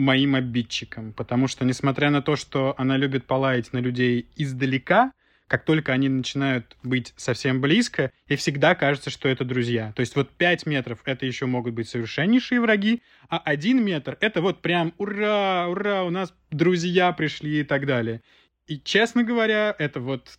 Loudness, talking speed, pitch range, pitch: -23 LUFS, 170 wpm, 130-175 Hz, 140 Hz